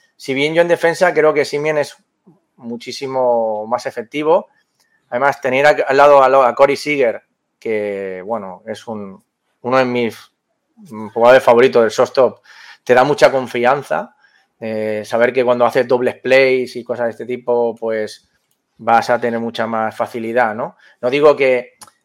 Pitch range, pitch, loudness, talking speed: 115-140 Hz, 125 Hz, -15 LUFS, 160 wpm